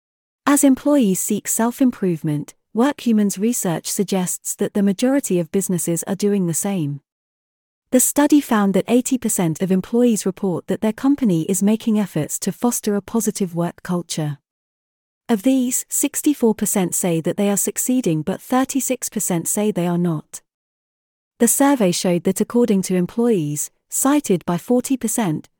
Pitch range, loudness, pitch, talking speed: 180-245 Hz, -19 LUFS, 205 Hz, 145 wpm